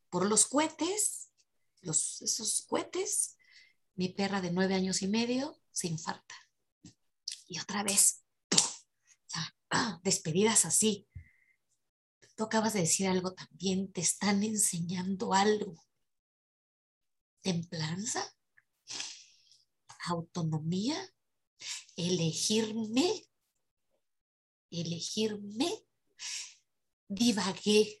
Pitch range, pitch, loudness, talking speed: 180-225 Hz, 200 Hz, -31 LUFS, 75 wpm